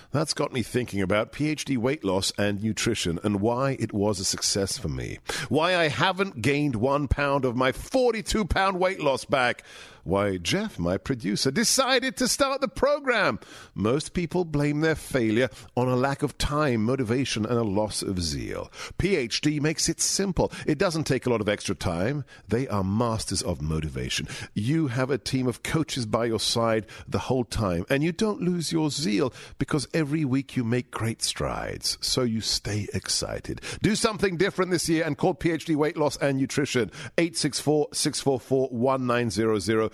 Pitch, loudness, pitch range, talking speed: 130 Hz, -26 LUFS, 110-155 Hz, 175 wpm